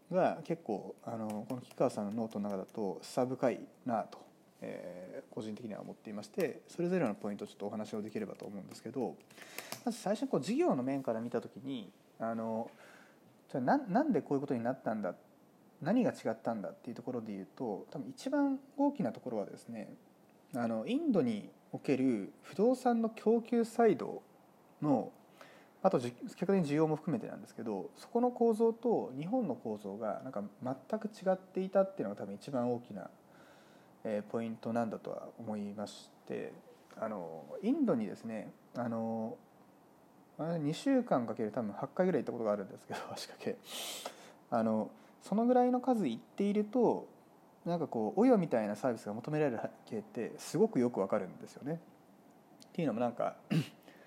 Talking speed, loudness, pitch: 350 characters per minute, -36 LUFS, 155 Hz